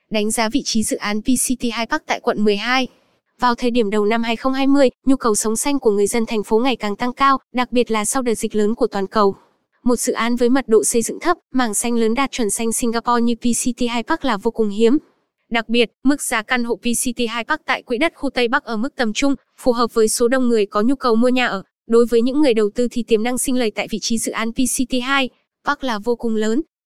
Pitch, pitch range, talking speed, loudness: 240 Hz, 225-255 Hz, 265 wpm, -19 LUFS